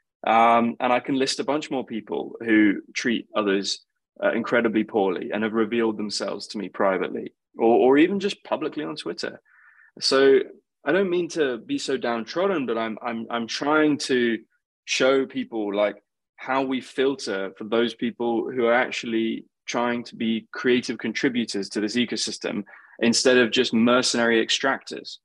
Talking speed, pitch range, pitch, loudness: 160 wpm, 110-130 Hz, 120 Hz, -23 LUFS